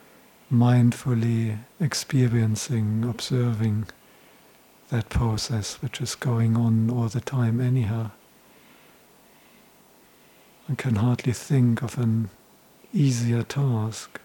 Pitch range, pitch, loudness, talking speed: 115-130 Hz, 120 Hz, -24 LUFS, 90 wpm